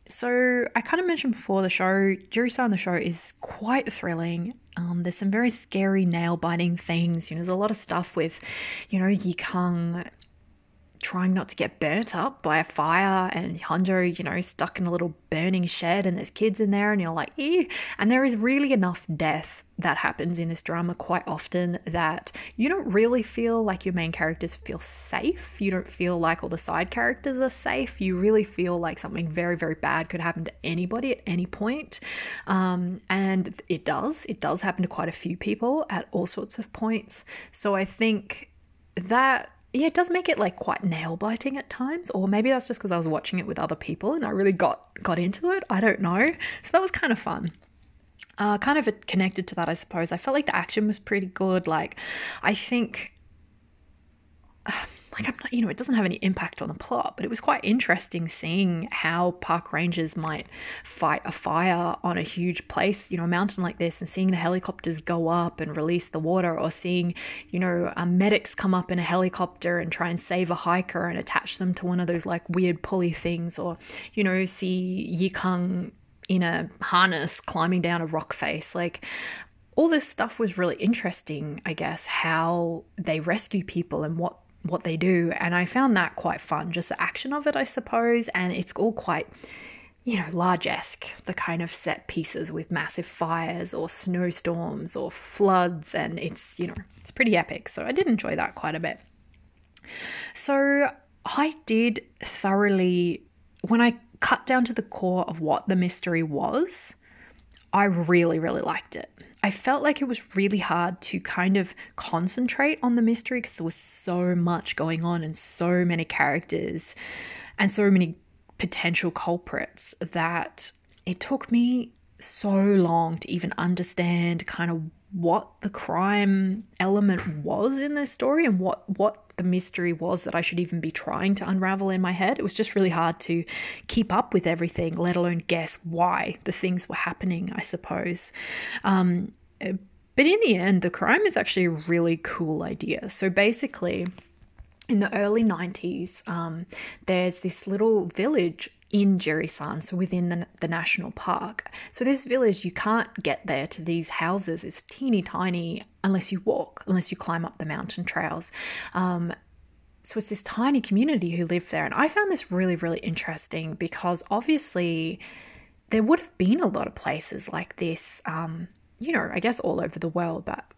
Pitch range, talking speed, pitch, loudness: 170-215 Hz, 190 wpm, 180 Hz, -26 LUFS